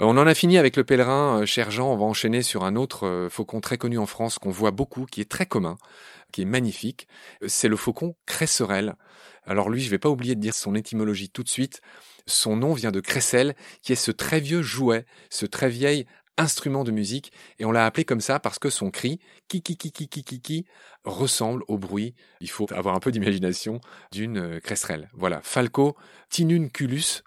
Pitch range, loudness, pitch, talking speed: 105-140 Hz, -24 LUFS, 125 Hz, 205 wpm